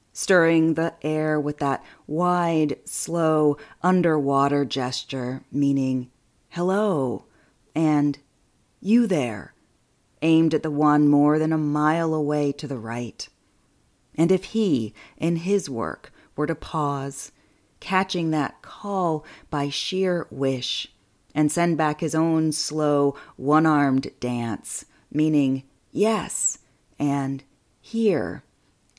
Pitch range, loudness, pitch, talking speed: 135-165 Hz, -23 LUFS, 150 Hz, 110 wpm